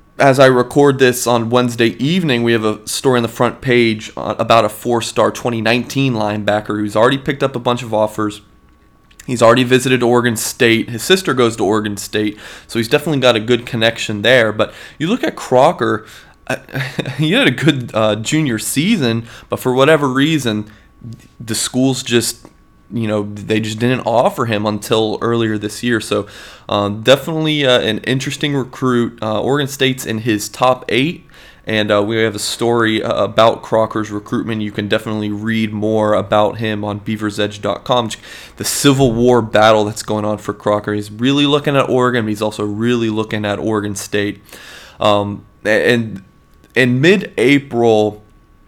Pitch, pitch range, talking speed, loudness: 115 Hz, 105-125 Hz, 170 wpm, -15 LUFS